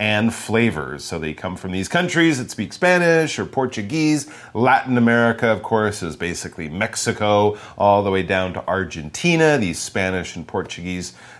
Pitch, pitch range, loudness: 105 Hz, 90-120 Hz, -20 LUFS